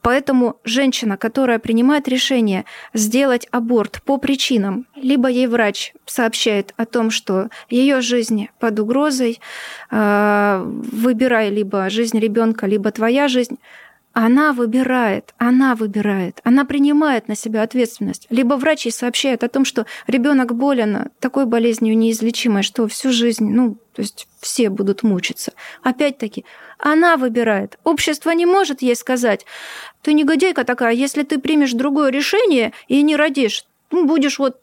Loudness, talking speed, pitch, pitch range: -17 LUFS, 135 wpm, 245 Hz, 225-275 Hz